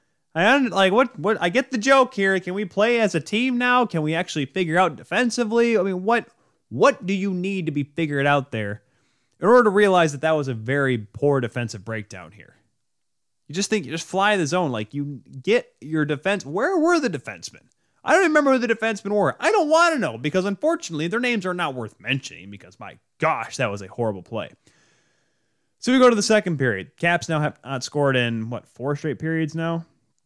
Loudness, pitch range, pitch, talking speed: -21 LUFS, 135-215 Hz, 165 Hz, 220 wpm